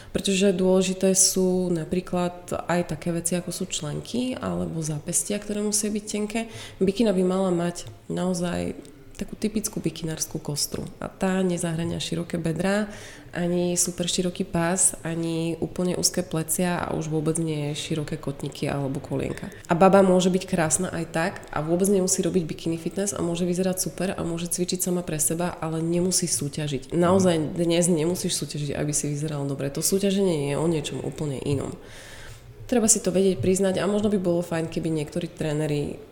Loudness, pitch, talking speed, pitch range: -25 LUFS, 175 Hz, 165 wpm, 155-185 Hz